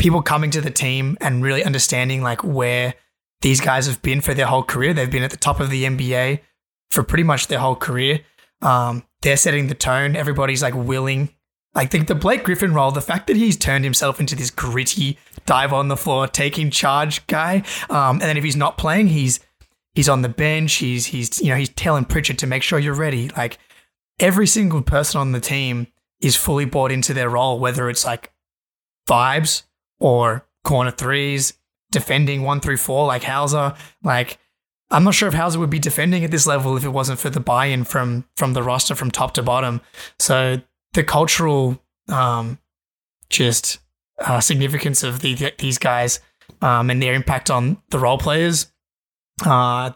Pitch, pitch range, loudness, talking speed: 135 Hz, 125-150 Hz, -18 LUFS, 190 wpm